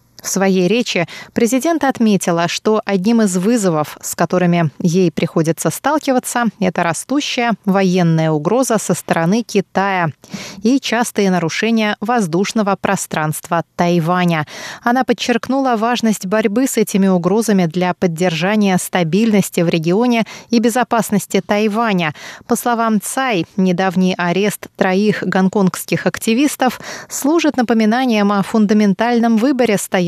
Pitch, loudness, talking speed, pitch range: 200 Hz, -15 LUFS, 110 wpm, 180-235 Hz